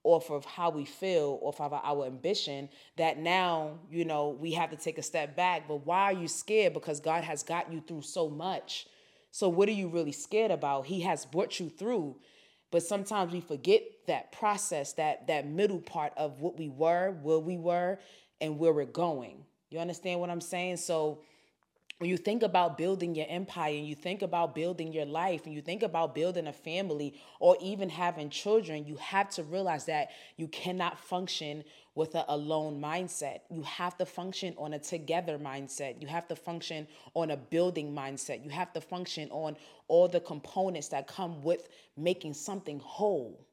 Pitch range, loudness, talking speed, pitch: 150-180 Hz, -33 LUFS, 190 wpm, 165 Hz